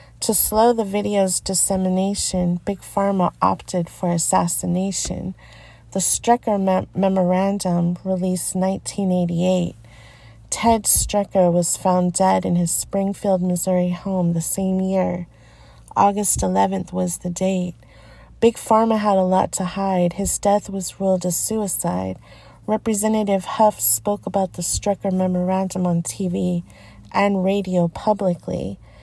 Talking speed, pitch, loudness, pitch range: 120 wpm, 185 Hz, -20 LUFS, 175-195 Hz